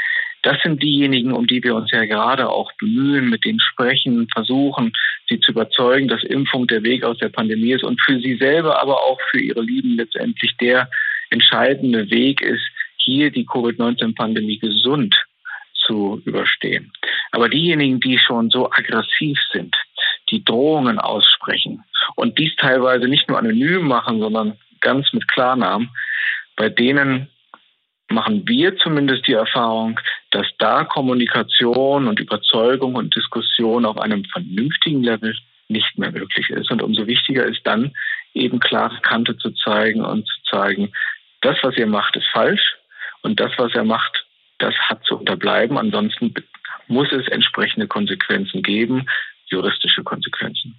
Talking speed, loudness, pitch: 150 wpm, -17 LUFS, 130 Hz